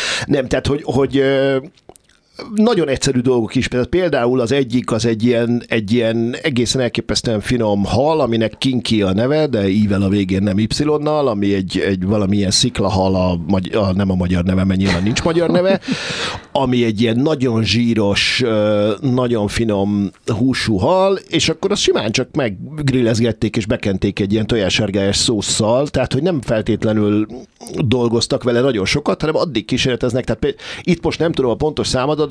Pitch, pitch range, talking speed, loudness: 120 Hz, 105-135 Hz, 160 wpm, -16 LUFS